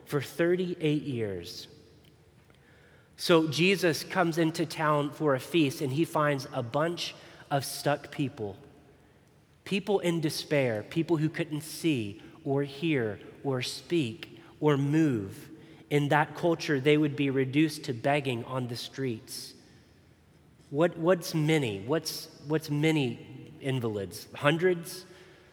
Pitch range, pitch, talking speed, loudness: 140-165 Hz, 150 Hz, 120 wpm, -29 LUFS